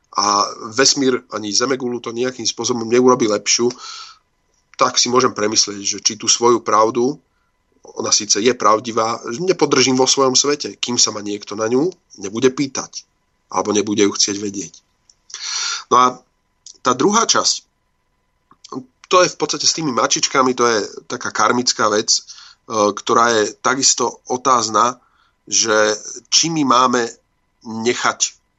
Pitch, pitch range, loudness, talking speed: 120 Hz, 105-130 Hz, -16 LUFS, 135 wpm